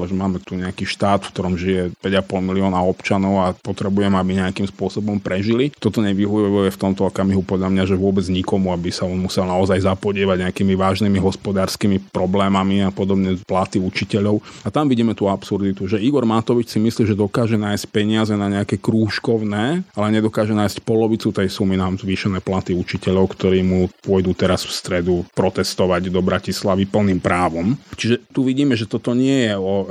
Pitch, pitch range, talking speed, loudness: 95 Hz, 95-105 Hz, 175 wpm, -19 LUFS